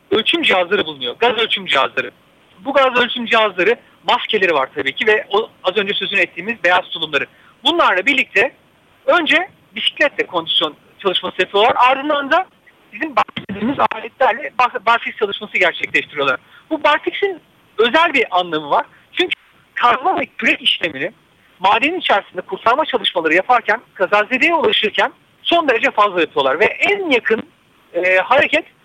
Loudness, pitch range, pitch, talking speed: -16 LUFS, 195-310 Hz, 235 Hz, 130 wpm